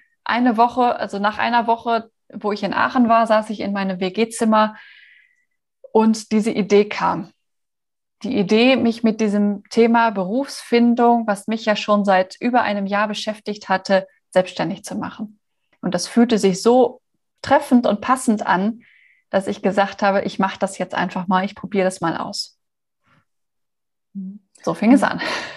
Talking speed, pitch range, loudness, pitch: 160 wpm, 200-235 Hz, -19 LUFS, 215 Hz